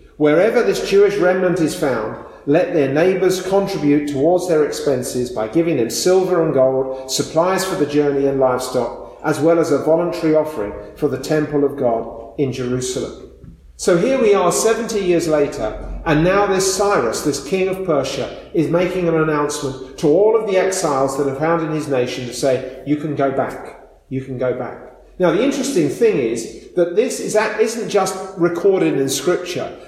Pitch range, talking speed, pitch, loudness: 135-185 Hz, 185 wpm, 155 Hz, -18 LUFS